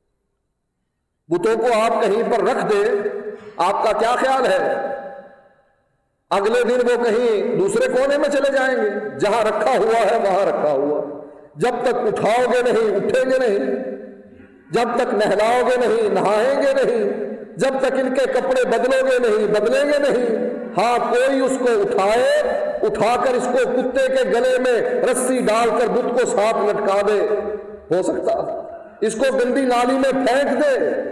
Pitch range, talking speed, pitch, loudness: 235-330 Hz, 165 wpm, 260 Hz, -18 LUFS